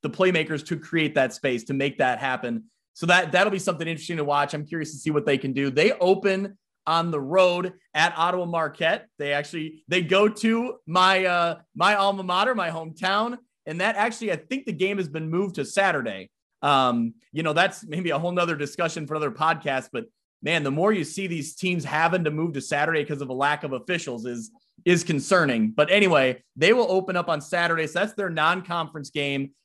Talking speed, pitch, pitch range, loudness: 215 wpm, 170 Hz, 150-190 Hz, -24 LUFS